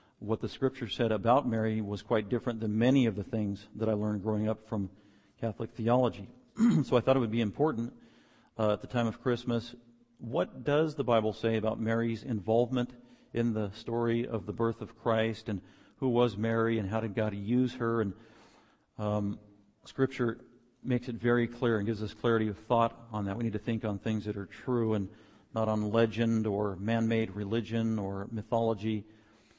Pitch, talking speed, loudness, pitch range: 115 Hz, 195 wpm, -31 LUFS, 105-120 Hz